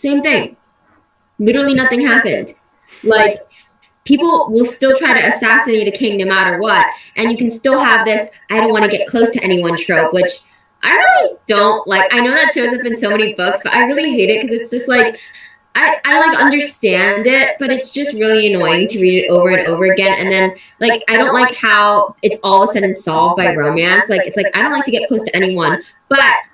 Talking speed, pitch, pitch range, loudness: 220 wpm, 225 Hz, 195-265 Hz, -12 LUFS